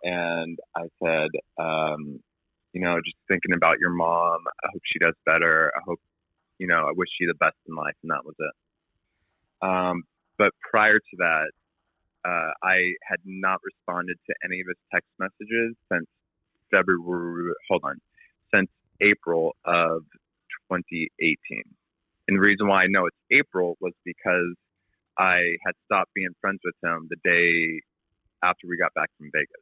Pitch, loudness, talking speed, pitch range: 90 Hz, -24 LUFS, 160 wpm, 85-95 Hz